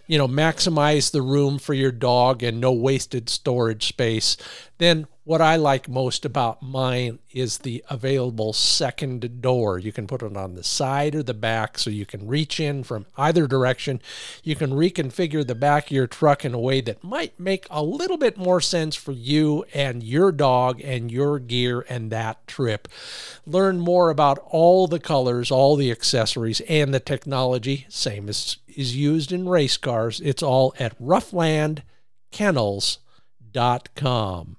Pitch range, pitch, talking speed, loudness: 120-150 Hz, 135 Hz, 165 wpm, -22 LUFS